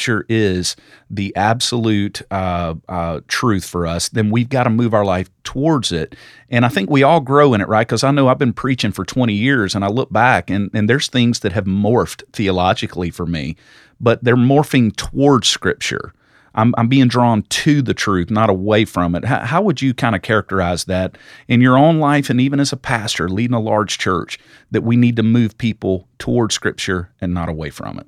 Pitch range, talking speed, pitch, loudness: 95-125 Hz, 210 wpm, 110 Hz, -16 LUFS